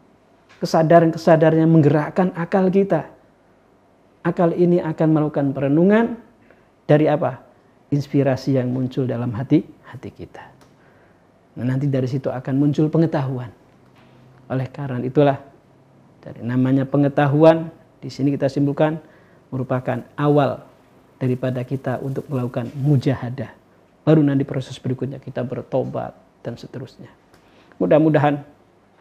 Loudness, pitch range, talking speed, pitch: -19 LUFS, 125-155 Hz, 110 wpm, 140 Hz